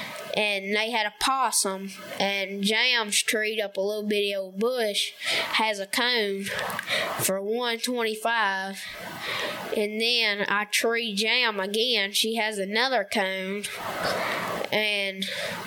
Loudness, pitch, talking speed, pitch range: -25 LUFS, 210 Hz, 125 wpm, 200-230 Hz